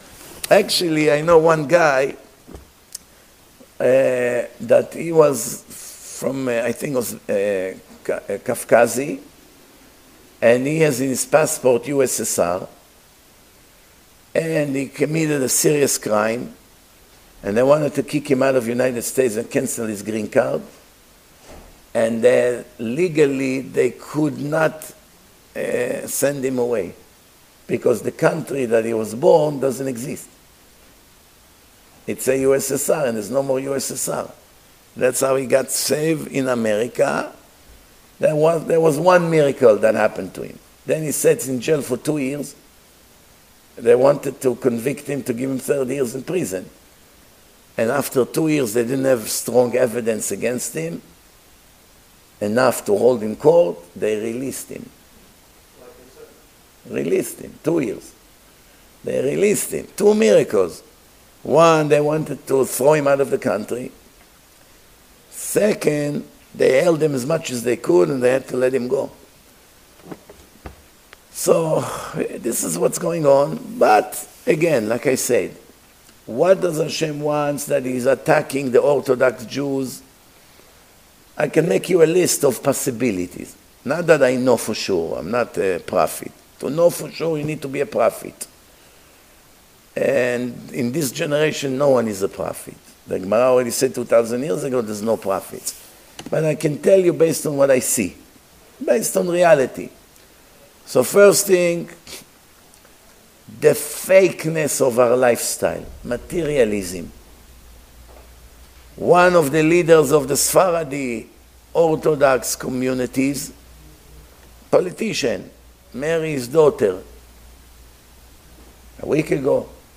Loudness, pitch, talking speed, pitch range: -19 LUFS, 135 Hz, 135 wpm, 120-155 Hz